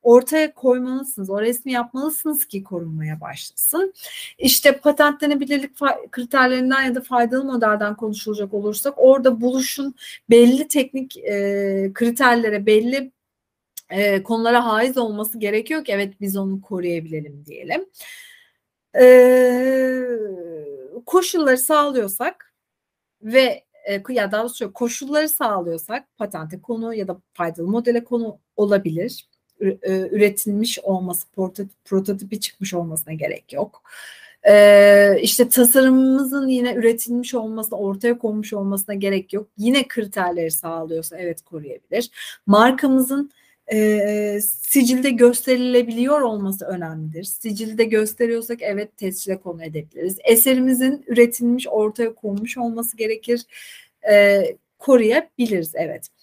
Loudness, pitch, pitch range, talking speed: -18 LUFS, 230 Hz, 200-260 Hz, 105 wpm